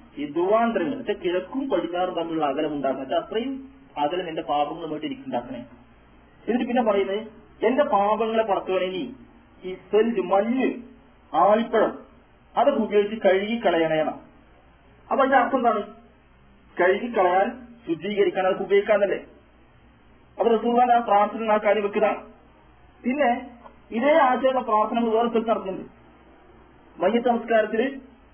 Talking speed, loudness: 95 wpm, -23 LUFS